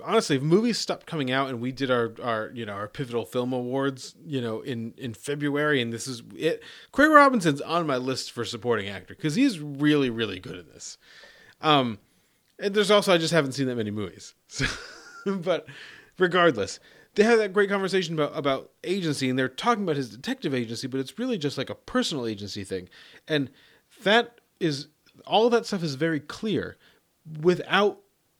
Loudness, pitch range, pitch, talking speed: -25 LUFS, 125-190 Hz, 145 Hz, 190 wpm